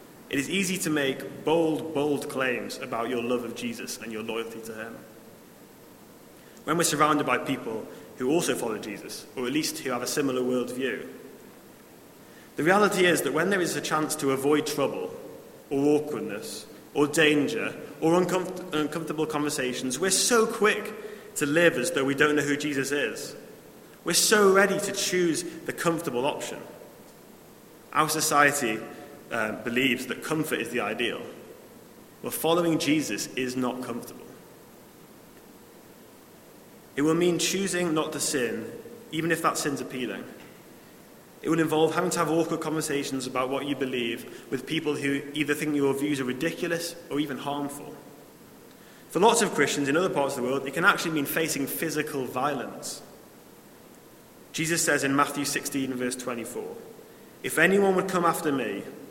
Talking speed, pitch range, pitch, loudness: 160 wpm, 135-170 Hz, 150 Hz, -26 LUFS